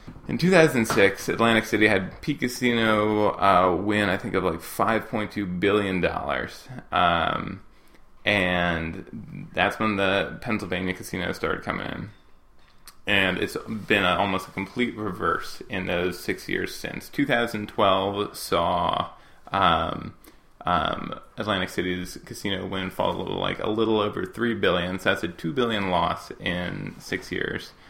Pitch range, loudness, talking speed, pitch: 90-110 Hz, -24 LUFS, 140 wpm, 100 Hz